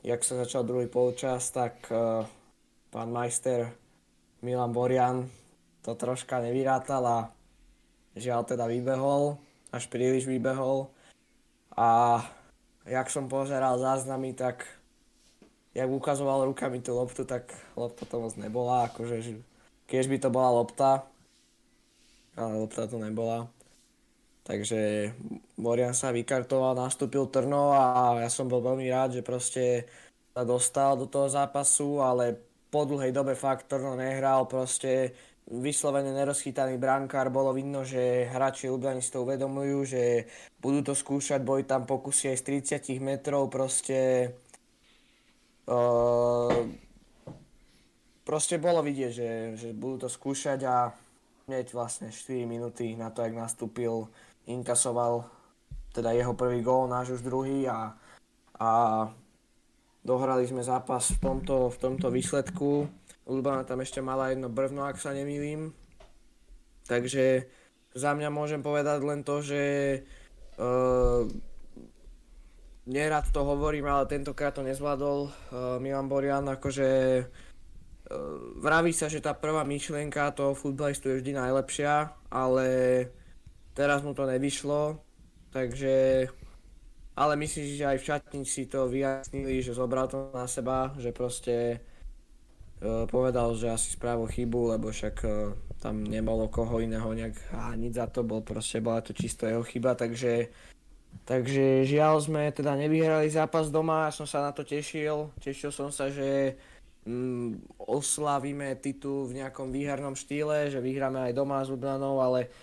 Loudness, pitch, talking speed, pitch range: -29 LUFS, 130 Hz, 135 wpm, 120-140 Hz